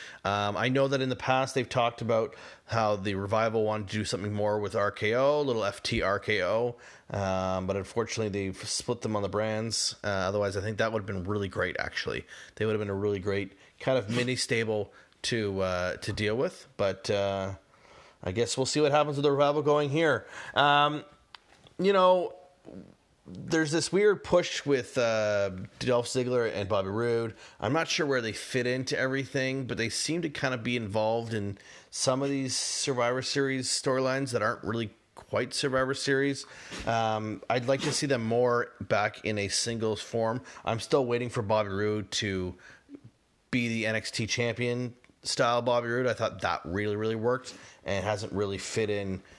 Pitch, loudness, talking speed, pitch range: 115 Hz, -29 LUFS, 185 wpm, 105-130 Hz